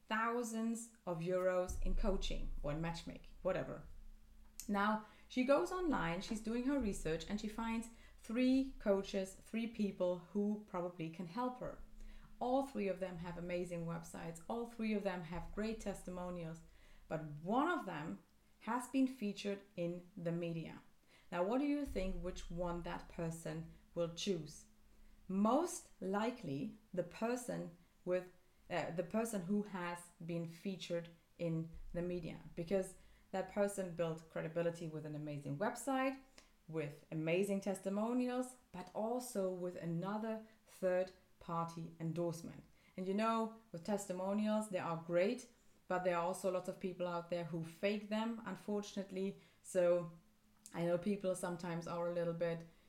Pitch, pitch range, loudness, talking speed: 185 Hz, 170-215 Hz, -41 LUFS, 145 wpm